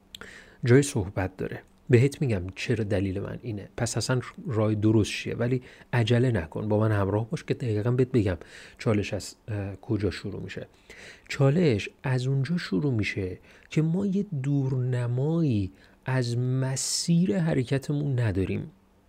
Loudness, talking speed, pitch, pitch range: -27 LUFS, 135 wpm, 120 Hz, 105-135 Hz